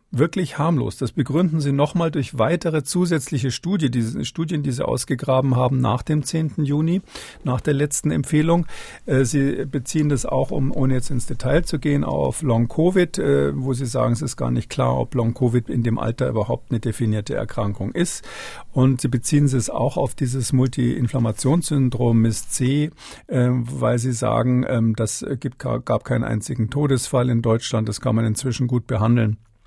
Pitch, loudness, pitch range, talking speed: 130 Hz, -21 LUFS, 120-145 Hz, 165 wpm